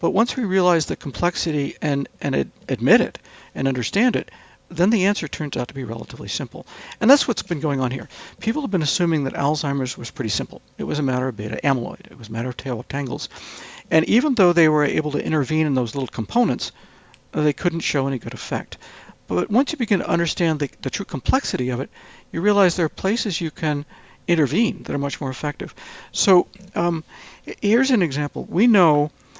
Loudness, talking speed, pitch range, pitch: -21 LUFS, 205 wpm, 135-185 Hz, 155 Hz